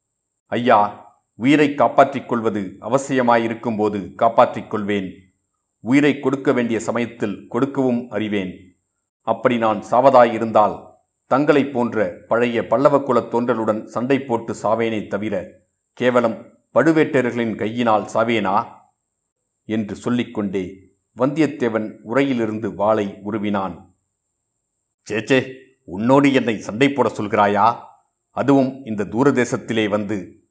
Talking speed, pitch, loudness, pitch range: 90 wpm, 115 Hz, -19 LUFS, 105-130 Hz